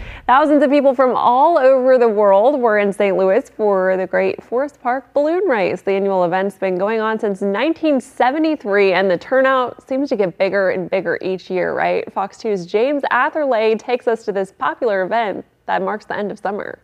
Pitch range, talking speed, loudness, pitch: 195-265 Hz, 195 wpm, -17 LUFS, 220 Hz